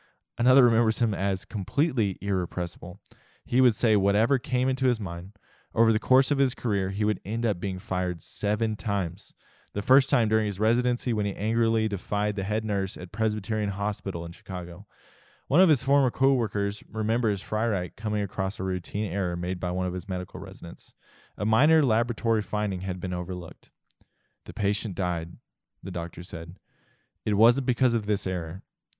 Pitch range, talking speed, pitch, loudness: 95-115 Hz, 175 wpm, 105 Hz, -27 LUFS